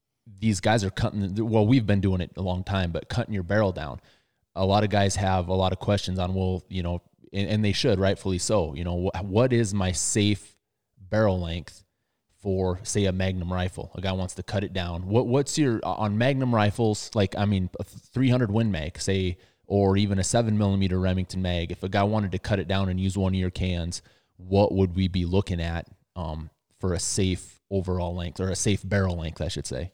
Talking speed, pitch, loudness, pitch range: 225 wpm, 95 Hz, -26 LUFS, 90-105 Hz